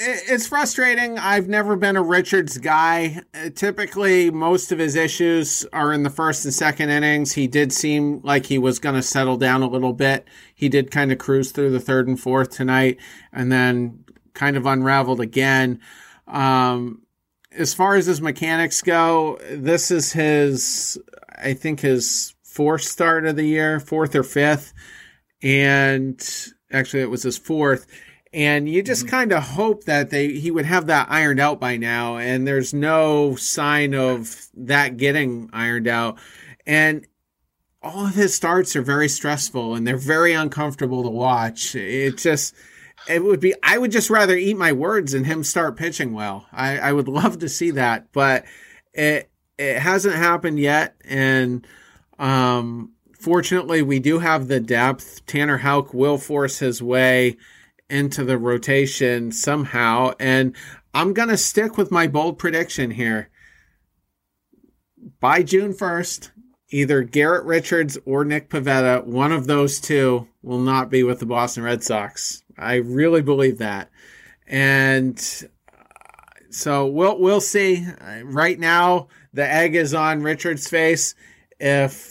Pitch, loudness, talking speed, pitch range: 145 Hz, -19 LUFS, 155 wpm, 130-165 Hz